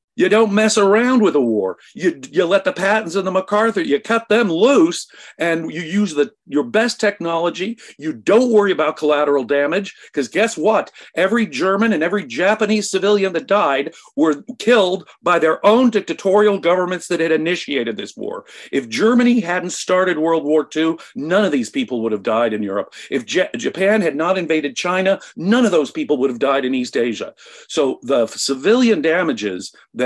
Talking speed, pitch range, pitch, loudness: 185 wpm, 160-215 Hz, 190 Hz, -17 LUFS